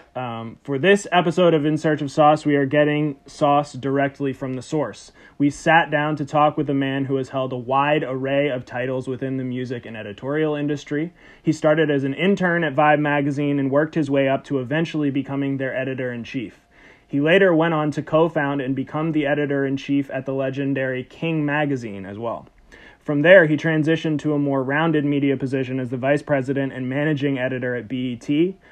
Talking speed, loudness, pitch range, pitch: 205 wpm, -21 LUFS, 135-150 Hz, 145 Hz